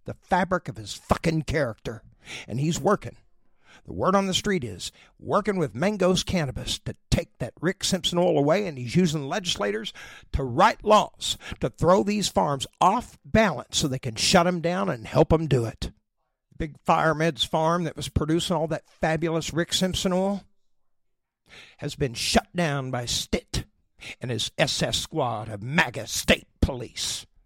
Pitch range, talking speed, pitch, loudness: 140-185 Hz, 170 wpm, 160 Hz, -25 LUFS